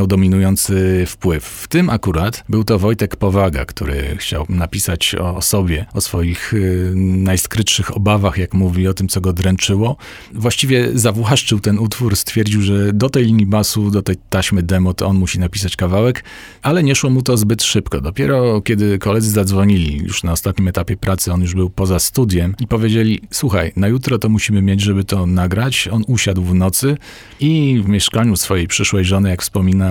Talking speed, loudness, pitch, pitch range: 180 wpm, -15 LUFS, 100 Hz, 95-110 Hz